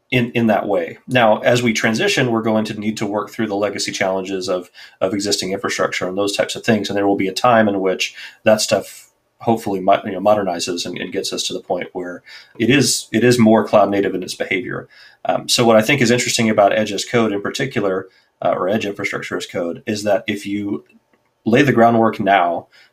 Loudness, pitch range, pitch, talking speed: -17 LUFS, 100-115 Hz, 105 Hz, 225 wpm